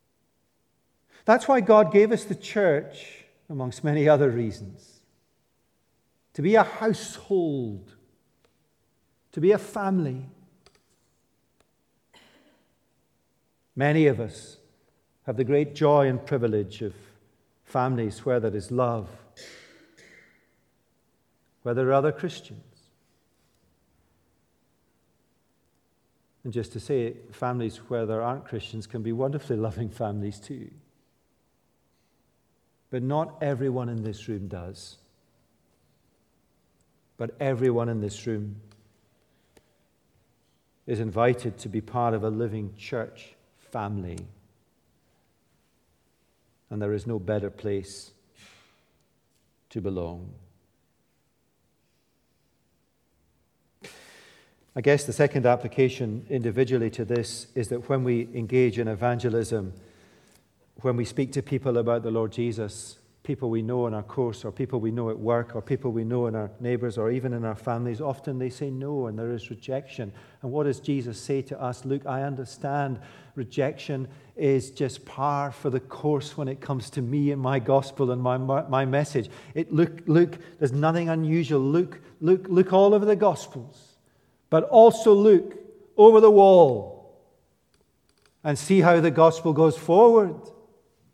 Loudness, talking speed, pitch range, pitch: -24 LUFS, 130 wpm, 110-145 Hz, 125 Hz